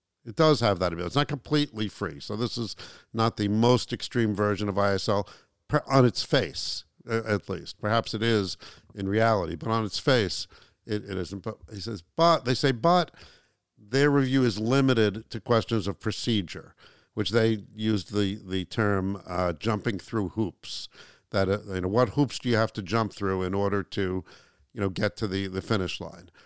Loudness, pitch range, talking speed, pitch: -27 LUFS, 100-115 Hz, 195 wpm, 110 Hz